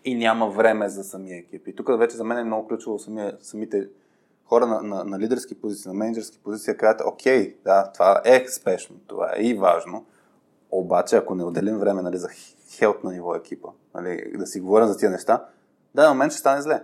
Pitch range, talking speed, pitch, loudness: 95-115 Hz, 210 wpm, 105 Hz, -22 LUFS